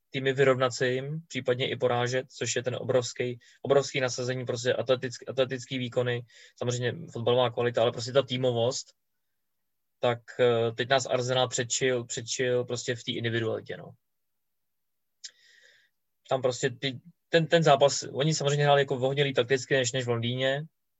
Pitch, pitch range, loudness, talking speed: 130 Hz, 125-135 Hz, -28 LUFS, 145 wpm